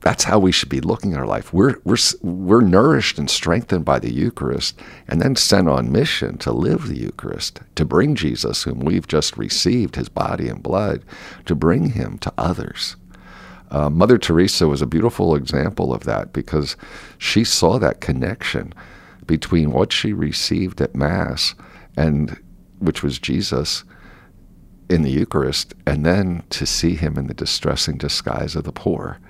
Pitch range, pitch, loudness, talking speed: 75-90 Hz, 80 Hz, -19 LUFS, 170 wpm